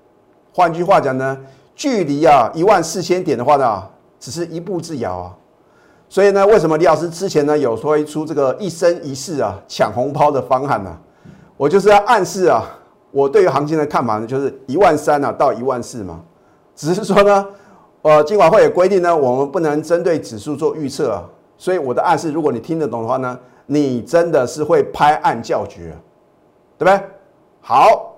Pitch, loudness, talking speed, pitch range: 160 Hz, -15 LUFS, 285 characters per minute, 135-195 Hz